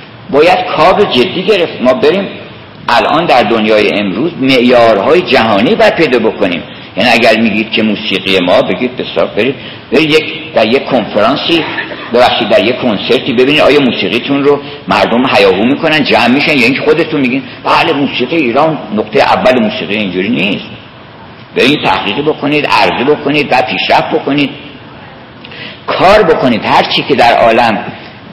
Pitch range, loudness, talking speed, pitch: 105-145 Hz, -9 LUFS, 155 wpm, 130 Hz